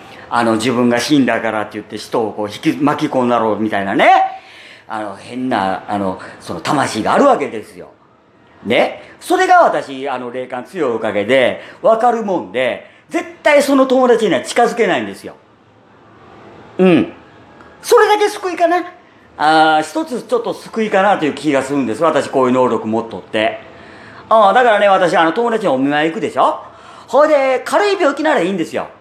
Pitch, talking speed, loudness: 170 Hz, 350 characters per minute, -15 LUFS